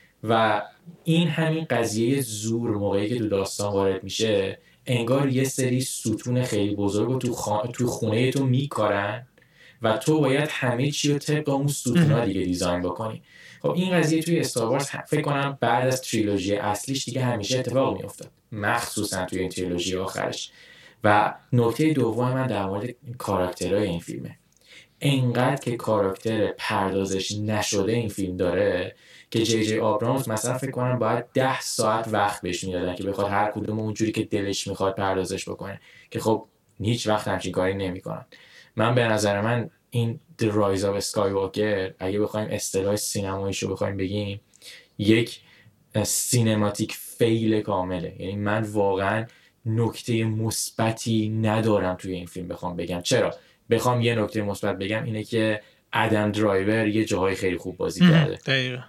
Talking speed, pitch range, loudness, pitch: 155 wpm, 100-125 Hz, -25 LUFS, 110 Hz